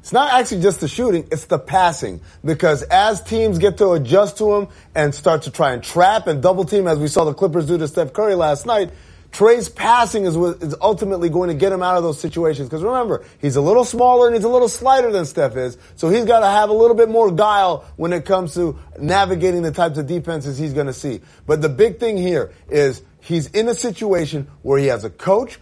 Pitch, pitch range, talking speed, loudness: 180 Hz, 155-215 Hz, 240 wpm, -17 LUFS